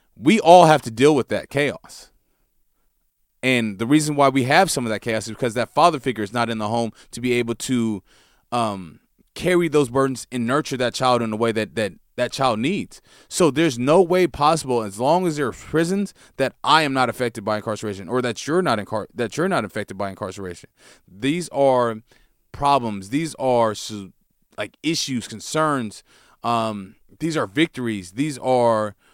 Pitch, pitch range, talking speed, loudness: 125 Hz, 110-145 Hz, 190 wpm, -21 LUFS